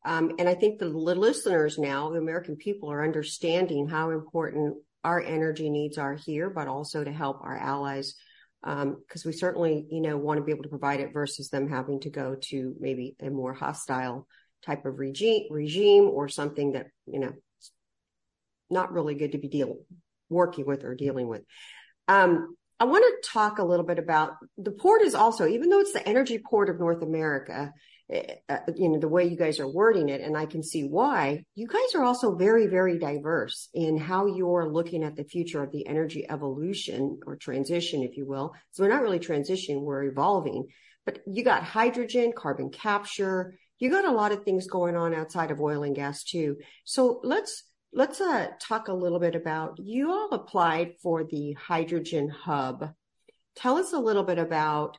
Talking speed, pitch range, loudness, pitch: 195 wpm, 145-190 Hz, -27 LUFS, 160 Hz